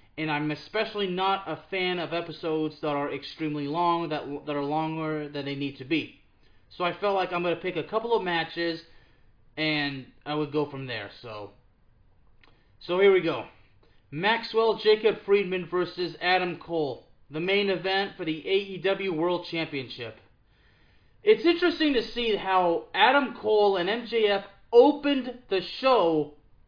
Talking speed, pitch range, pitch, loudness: 160 wpm, 145-200 Hz, 170 Hz, -26 LUFS